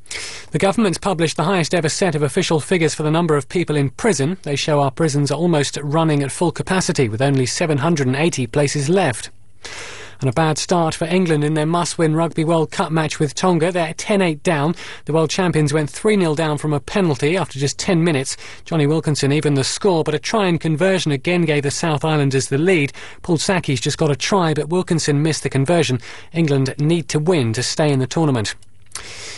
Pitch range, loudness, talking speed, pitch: 145-175 Hz, -18 LUFS, 205 wpm, 155 Hz